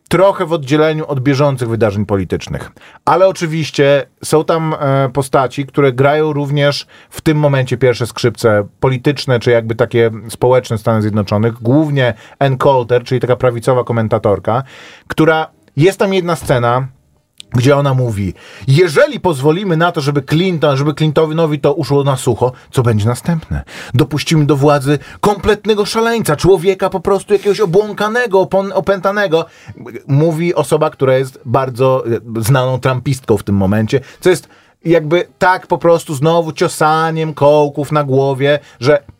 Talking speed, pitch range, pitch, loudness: 140 wpm, 125-165 Hz, 145 Hz, -13 LUFS